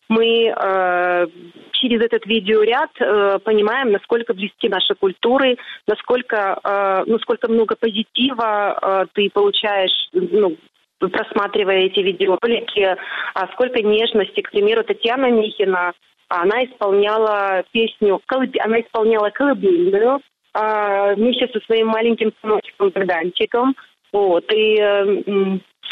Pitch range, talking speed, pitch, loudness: 200-235 Hz, 105 wpm, 215 Hz, -18 LUFS